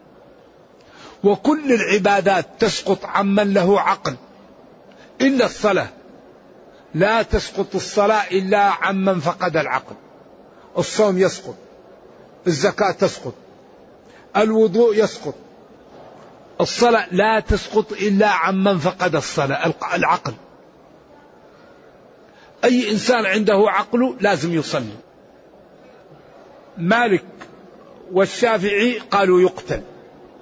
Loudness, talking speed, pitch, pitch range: -18 LUFS, 75 wpm, 205 Hz, 190-220 Hz